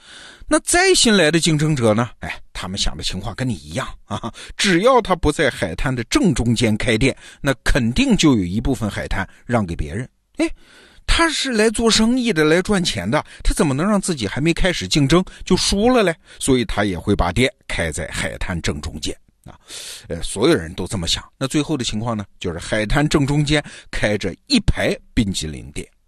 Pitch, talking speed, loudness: 130 Hz, 280 characters per minute, -19 LUFS